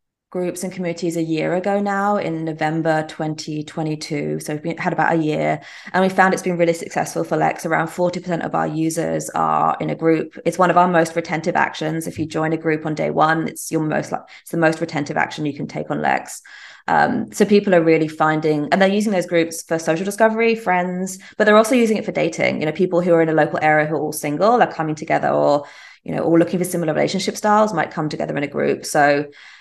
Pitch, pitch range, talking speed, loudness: 165 Hz, 155-180 Hz, 240 wpm, -19 LUFS